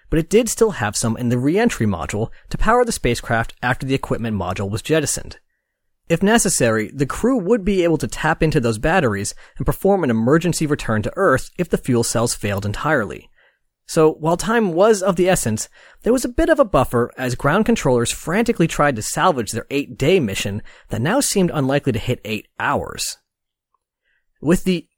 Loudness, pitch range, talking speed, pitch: -19 LUFS, 120-190 Hz, 195 wpm, 145 Hz